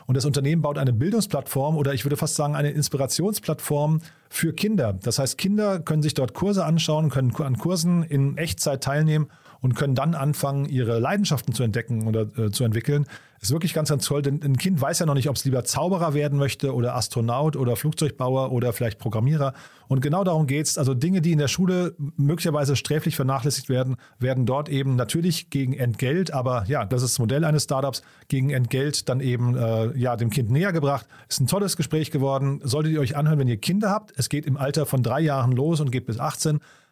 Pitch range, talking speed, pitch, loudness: 130-155 Hz, 210 wpm, 140 Hz, -23 LUFS